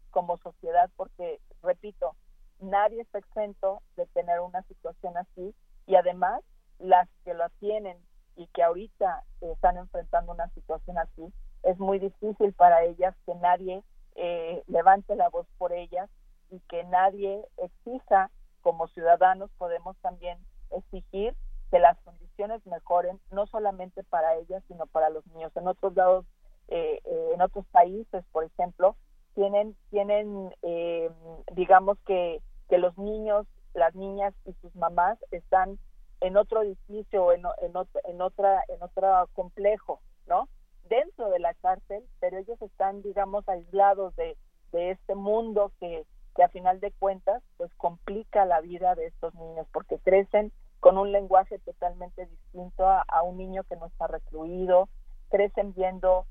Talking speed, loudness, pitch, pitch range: 150 wpm, -27 LUFS, 185 Hz, 175-205 Hz